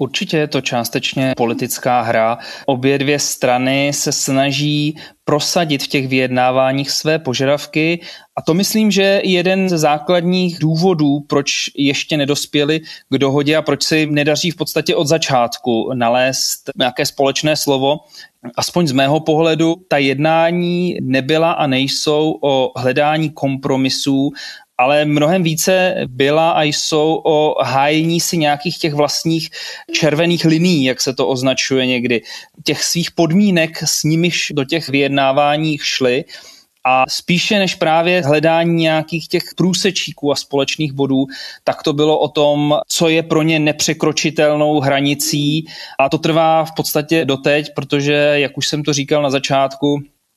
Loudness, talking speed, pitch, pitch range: -15 LUFS, 140 wpm, 150 Hz, 140-165 Hz